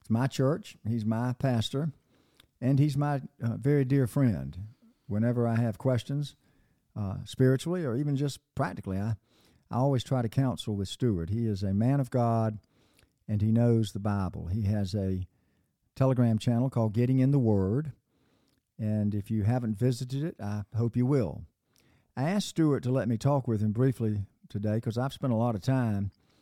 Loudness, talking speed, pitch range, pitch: -29 LUFS, 180 wpm, 105-130 Hz, 120 Hz